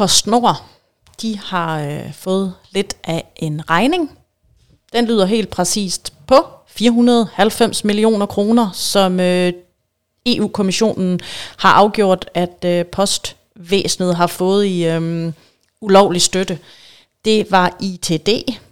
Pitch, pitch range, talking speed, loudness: 195 Hz, 180-215 Hz, 105 wpm, -16 LUFS